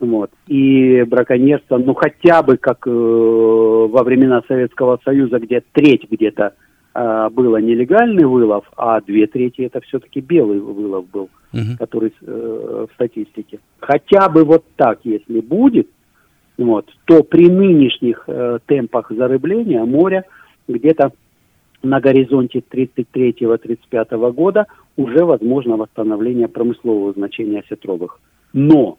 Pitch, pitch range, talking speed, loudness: 125 Hz, 115-135 Hz, 120 wpm, -14 LUFS